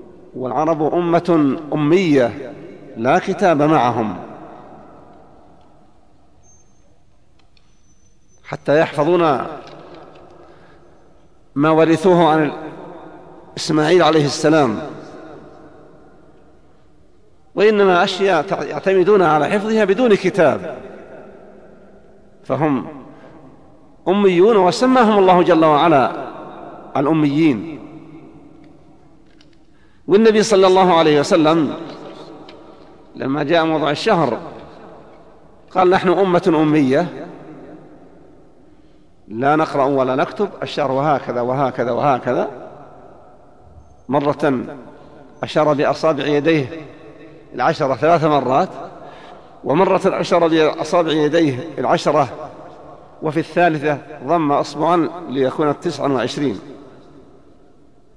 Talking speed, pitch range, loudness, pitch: 70 wpm, 145-175 Hz, -16 LUFS, 155 Hz